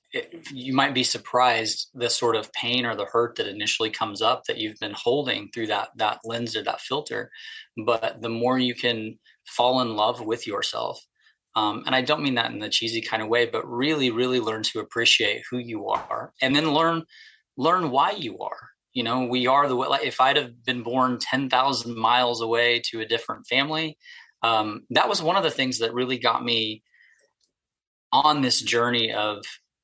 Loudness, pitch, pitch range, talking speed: -24 LUFS, 120 Hz, 115-130 Hz, 200 wpm